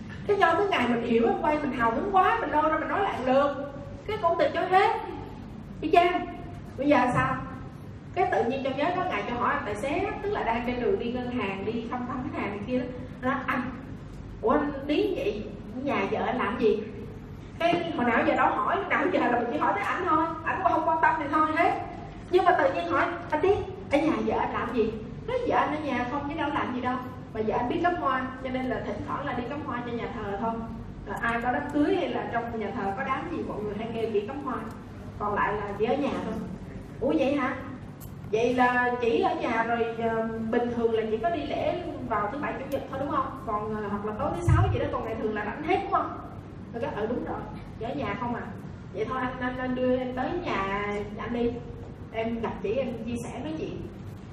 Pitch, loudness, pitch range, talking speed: 255 Hz, -28 LUFS, 230-320 Hz, 250 wpm